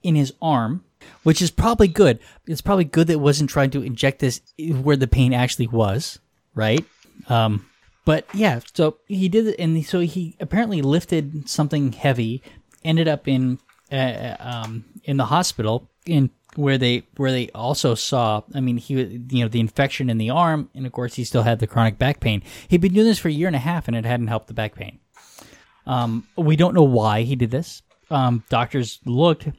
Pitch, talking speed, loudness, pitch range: 135 Hz, 205 wpm, -21 LUFS, 120-160 Hz